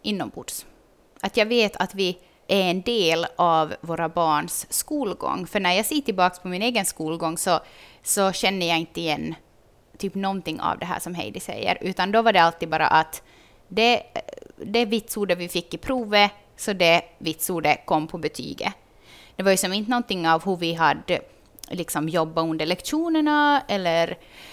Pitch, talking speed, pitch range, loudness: 180 Hz, 170 wpm, 165-210 Hz, -23 LUFS